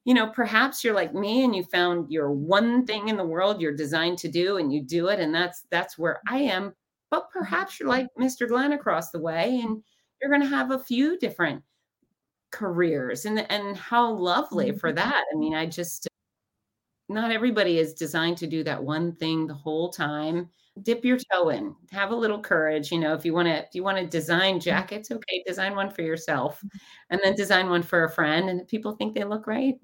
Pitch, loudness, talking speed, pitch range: 185 Hz, -25 LUFS, 215 wpm, 165-225 Hz